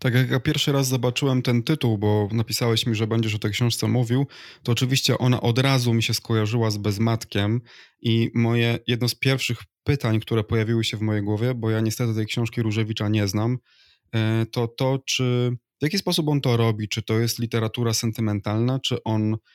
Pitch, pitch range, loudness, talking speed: 115 Hz, 110-125 Hz, -23 LUFS, 195 wpm